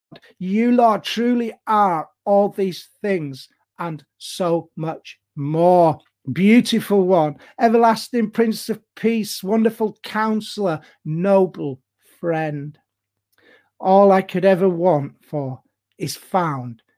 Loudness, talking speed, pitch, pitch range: -19 LUFS, 105 wpm, 190 Hz, 160-220 Hz